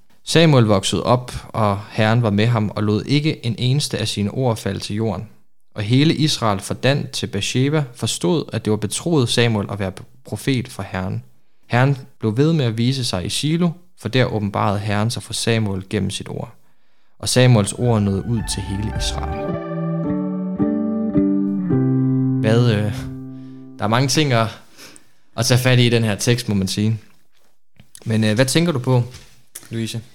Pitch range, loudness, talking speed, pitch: 100-130 Hz, -19 LUFS, 175 wpm, 115 Hz